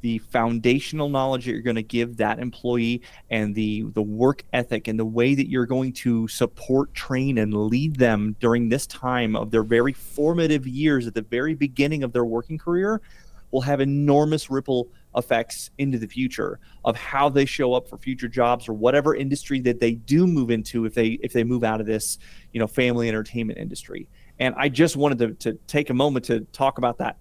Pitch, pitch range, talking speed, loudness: 125 Hz, 115-135 Hz, 205 wpm, -23 LUFS